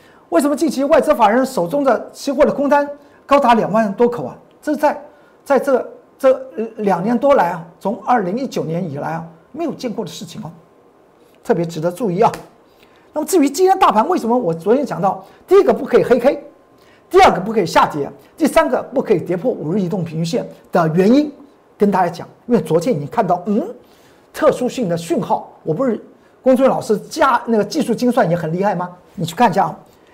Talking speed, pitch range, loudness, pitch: 305 characters per minute, 185-280 Hz, -16 LUFS, 240 Hz